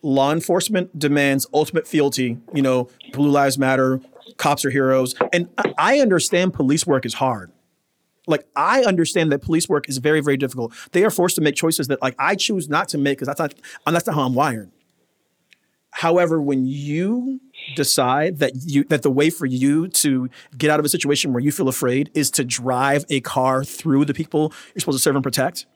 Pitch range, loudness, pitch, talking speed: 135-165 Hz, -19 LUFS, 145 Hz, 200 wpm